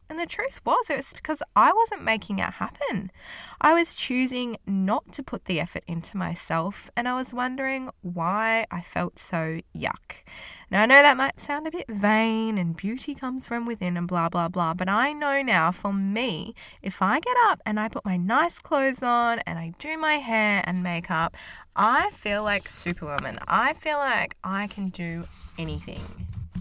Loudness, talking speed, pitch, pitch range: -25 LUFS, 190 wpm, 215 Hz, 175-265 Hz